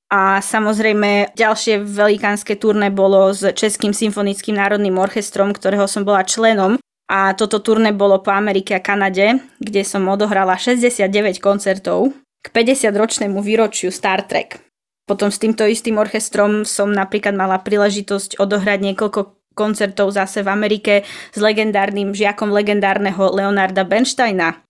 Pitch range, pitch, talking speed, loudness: 195-215 Hz, 205 Hz, 130 wpm, -16 LUFS